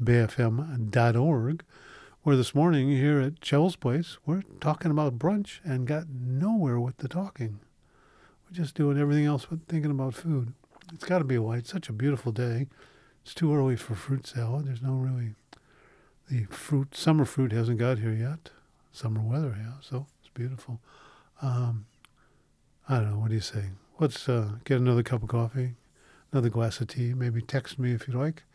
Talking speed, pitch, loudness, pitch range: 180 wpm, 130 Hz, -29 LUFS, 120-150 Hz